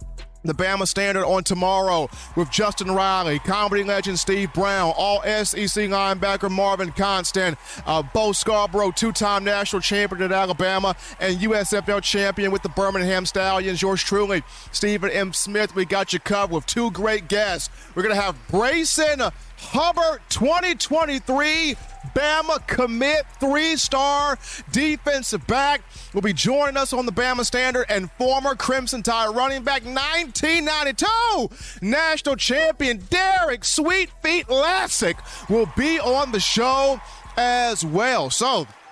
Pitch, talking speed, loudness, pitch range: 210 Hz, 135 wpm, -21 LUFS, 195-275 Hz